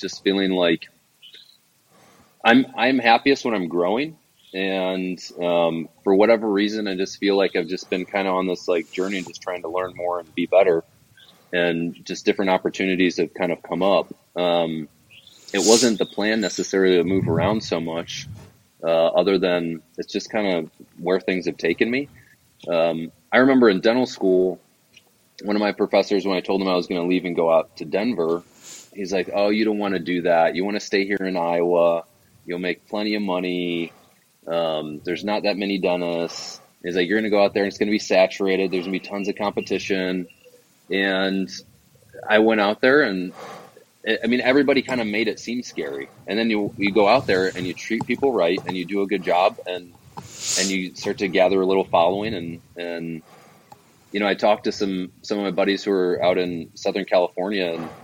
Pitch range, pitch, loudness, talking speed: 85-105 Hz, 95 Hz, -21 LUFS, 205 wpm